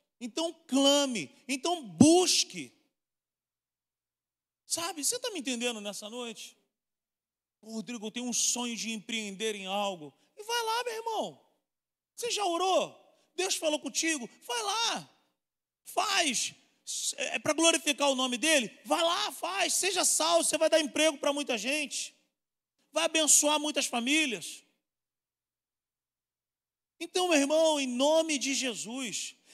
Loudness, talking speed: -28 LUFS, 130 wpm